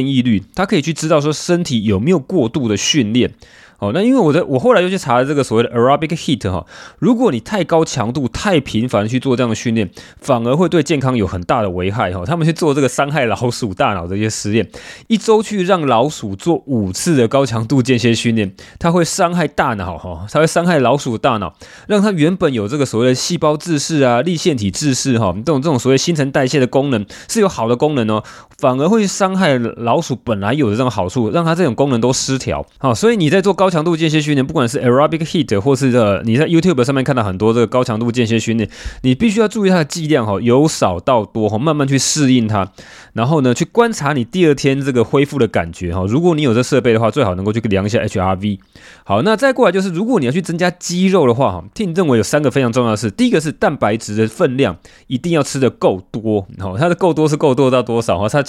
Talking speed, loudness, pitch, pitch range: 385 characters per minute, -15 LUFS, 130 Hz, 115-165 Hz